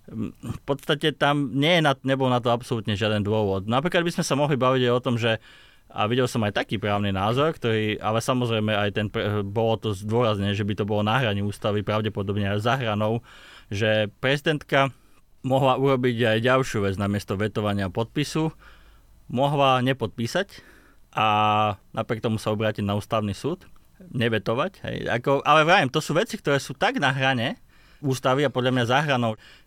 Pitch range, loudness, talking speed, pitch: 105-135 Hz, -24 LUFS, 180 wpm, 120 Hz